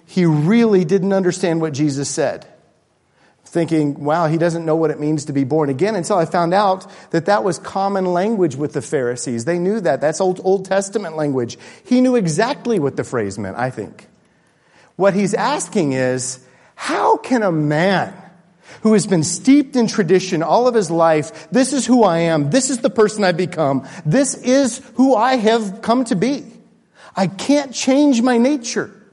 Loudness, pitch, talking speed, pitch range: -17 LUFS, 190 Hz, 185 wpm, 160-225 Hz